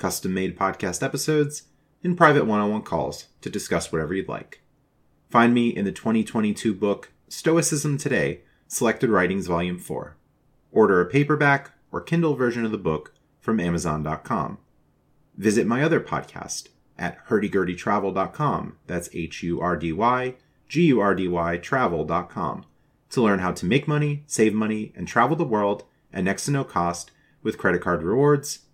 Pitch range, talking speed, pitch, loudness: 90-140 Hz, 155 wpm, 110 Hz, -23 LUFS